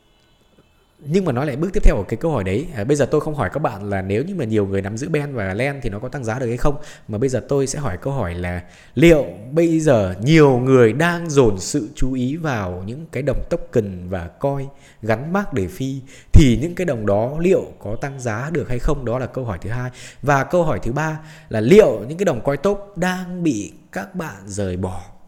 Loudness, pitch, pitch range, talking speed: -20 LUFS, 130 Hz, 105-155 Hz, 250 wpm